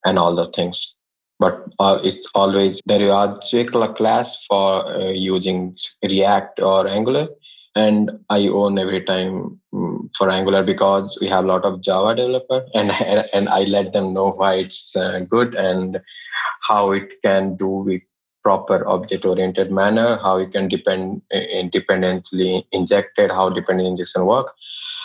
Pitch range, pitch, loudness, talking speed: 95-105 Hz, 95 Hz, -19 LUFS, 155 wpm